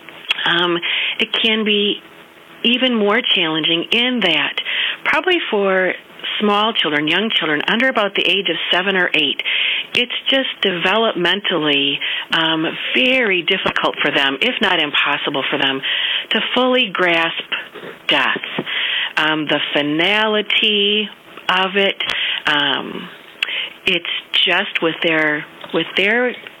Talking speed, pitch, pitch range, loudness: 115 wpm, 190 Hz, 160-220 Hz, -16 LUFS